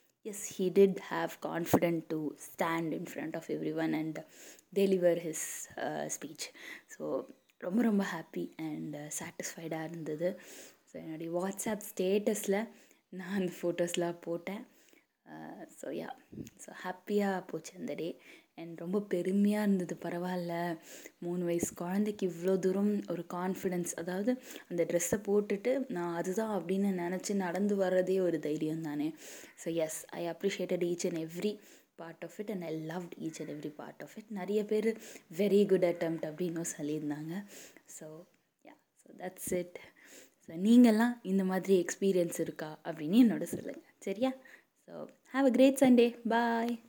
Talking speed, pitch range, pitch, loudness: 130 wpm, 170-205 Hz, 180 Hz, -33 LUFS